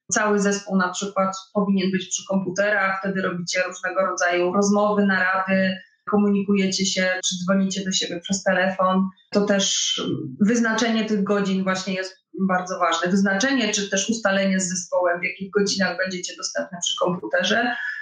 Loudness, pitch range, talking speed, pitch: -22 LUFS, 185-200 Hz, 145 wpm, 190 Hz